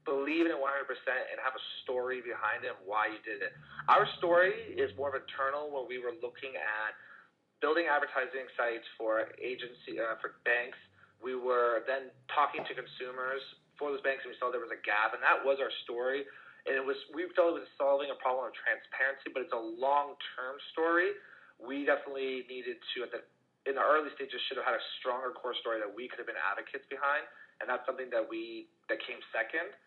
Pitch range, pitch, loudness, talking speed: 130-175 Hz, 140 Hz, -34 LUFS, 210 wpm